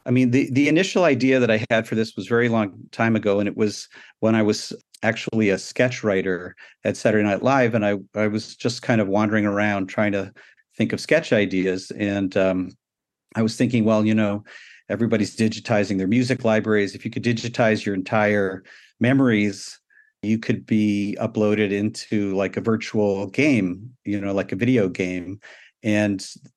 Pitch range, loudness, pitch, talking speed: 100-115 Hz, -22 LUFS, 105 Hz, 185 wpm